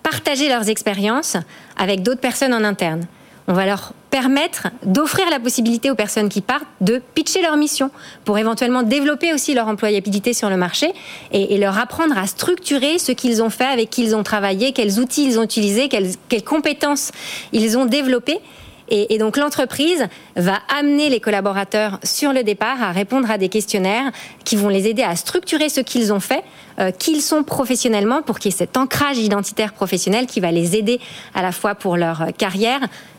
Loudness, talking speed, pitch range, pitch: -18 LUFS, 185 wpm, 205-275 Hz, 230 Hz